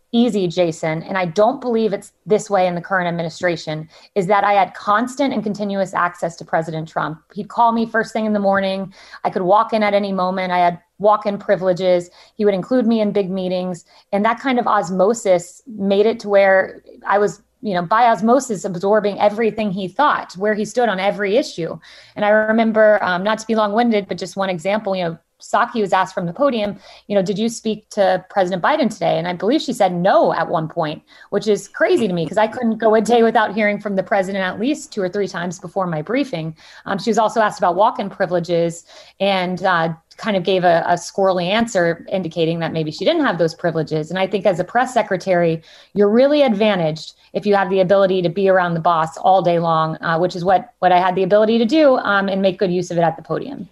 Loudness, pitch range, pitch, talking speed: -18 LUFS, 180-215 Hz, 195 Hz, 235 wpm